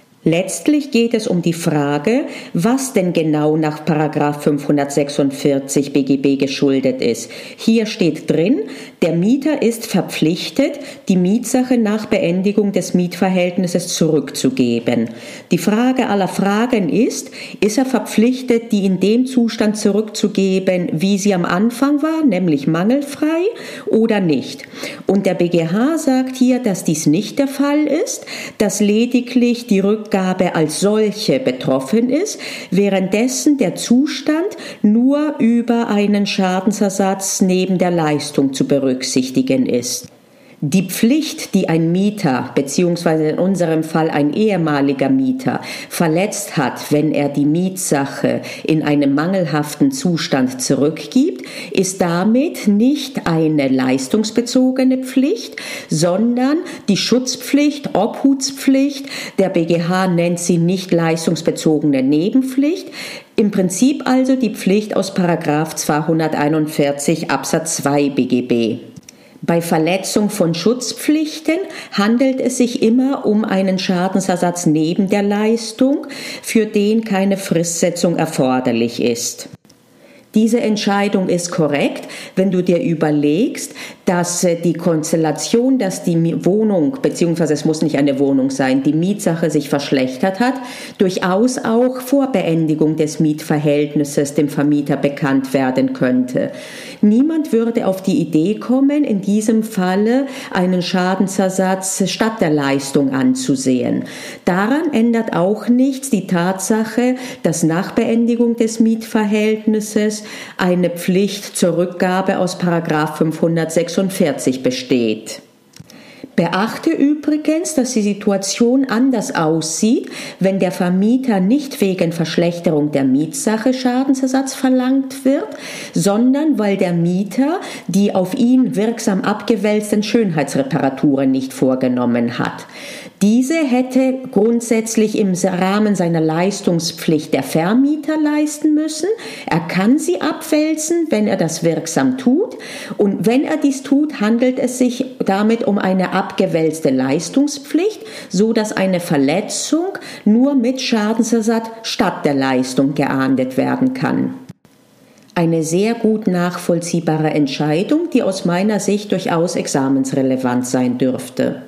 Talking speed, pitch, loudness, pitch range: 115 wpm, 200 Hz, -16 LUFS, 160-250 Hz